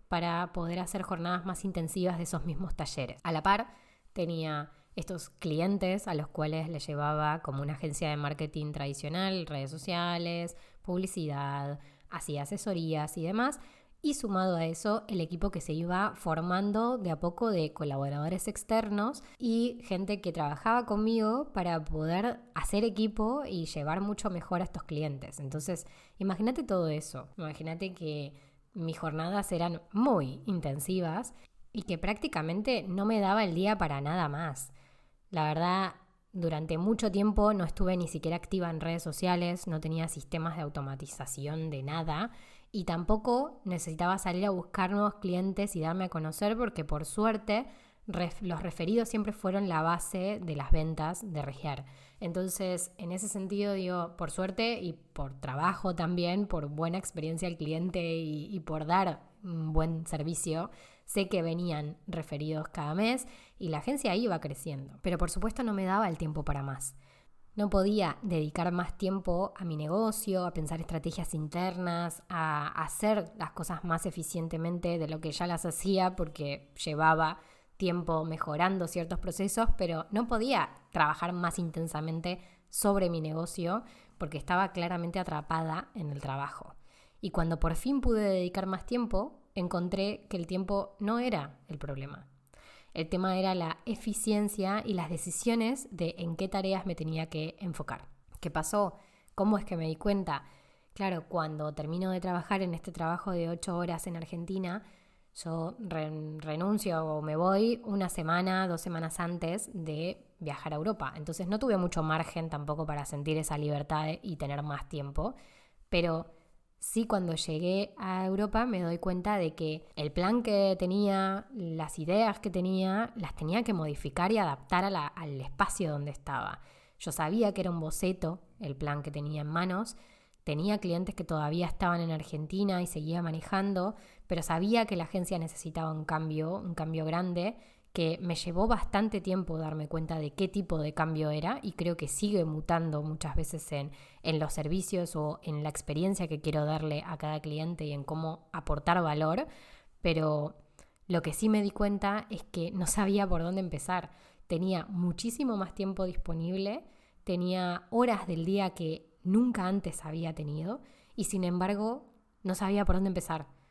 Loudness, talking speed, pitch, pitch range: -33 LUFS, 165 wpm, 175 Hz, 160-195 Hz